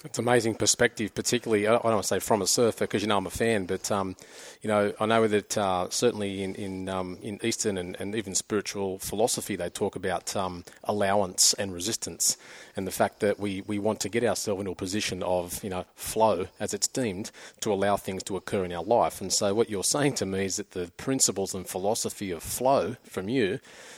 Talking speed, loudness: 225 wpm, -27 LUFS